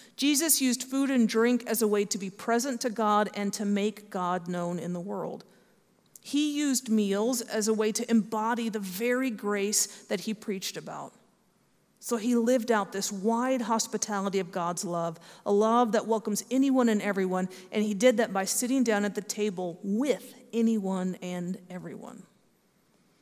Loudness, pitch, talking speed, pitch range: -28 LUFS, 215 Hz, 175 wpm, 200-235 Hz